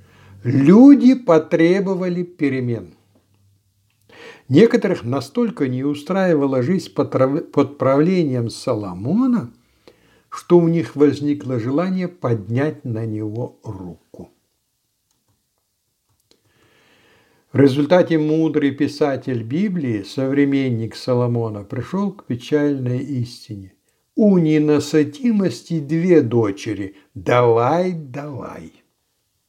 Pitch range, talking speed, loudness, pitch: 120-165 Hz, 75 wpm, -18 LUFS, 140 Hz